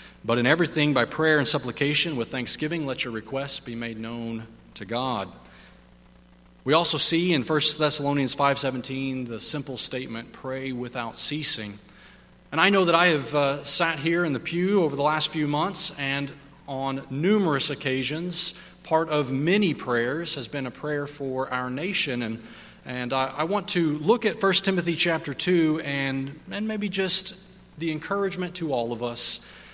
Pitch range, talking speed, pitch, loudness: 130-165 Hz, 170 wpm, 145 Hz, -24 LUFS